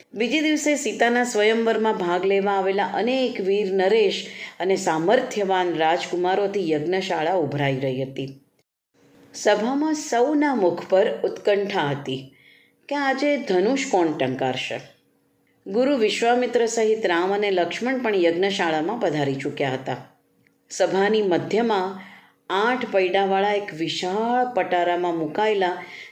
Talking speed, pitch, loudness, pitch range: 110 wpm, 195 Hz, -22 LUFS, 165-225 Hz